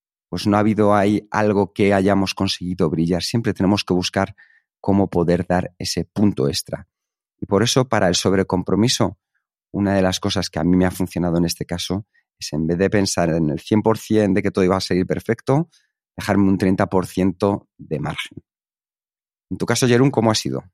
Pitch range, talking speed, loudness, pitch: 90-105 Hz, 190 wpm, -19 LUFS, 95 Hz